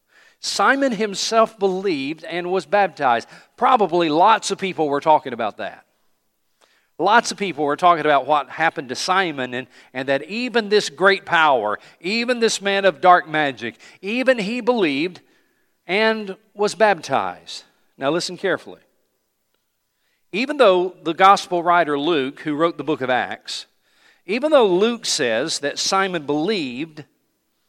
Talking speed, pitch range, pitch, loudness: 140 wpm, 160-225 Hz, 190 Hz, -19 LUFS